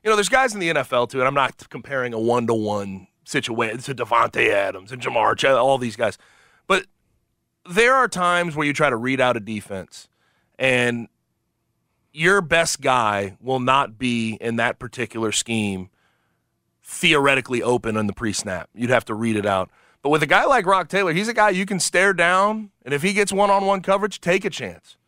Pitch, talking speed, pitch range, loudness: 130 Hz, 210 wpm, 110-185 Hz, -20 LUFS